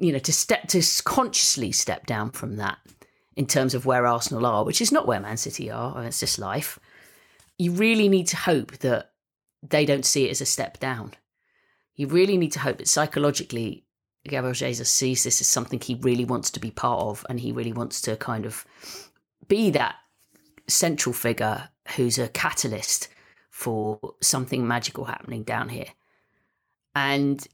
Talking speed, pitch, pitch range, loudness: 180 wpm, 130 Hz, 120-150 Hz, -24 LUFS